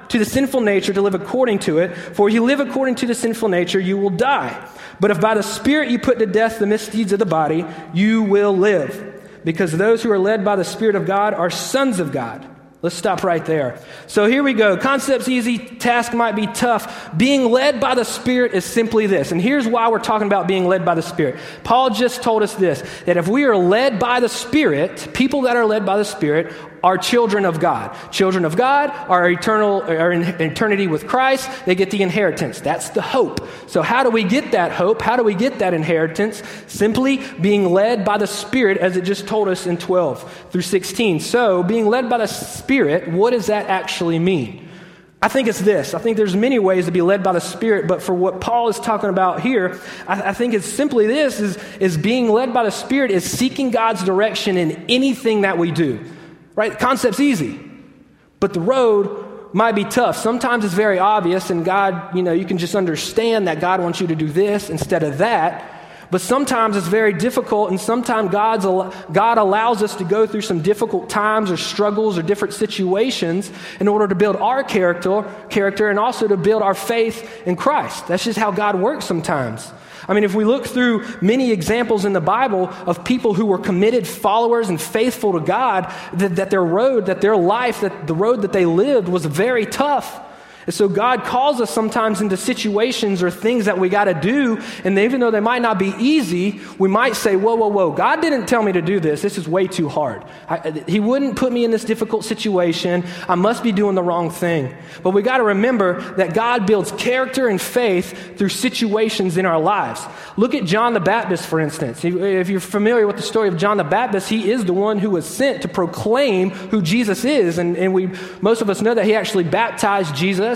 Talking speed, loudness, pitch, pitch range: 220 wpm, -17 LUFS, 205 Hz, 185-230 Hz